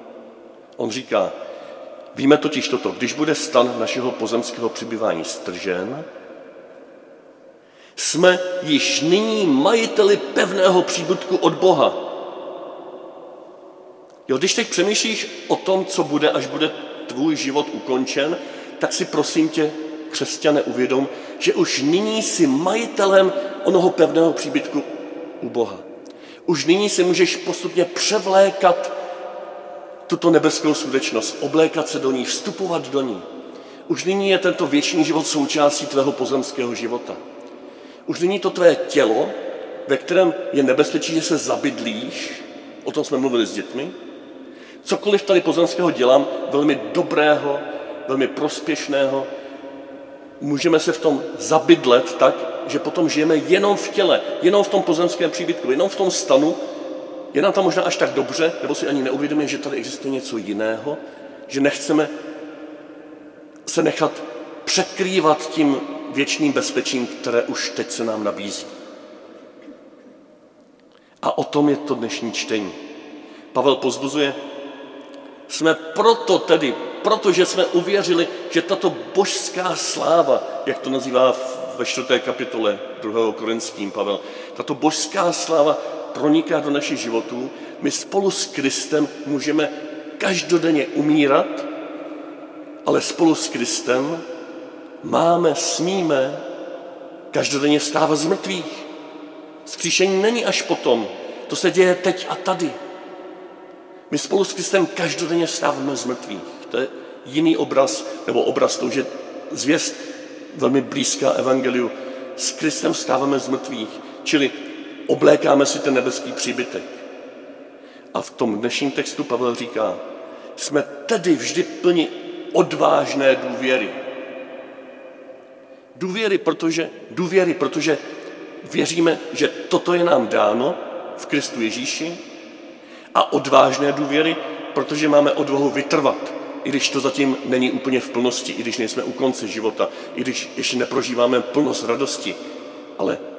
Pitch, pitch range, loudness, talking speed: 165 Hz, 140-195 Hz, -20 LUFS, 125 wpm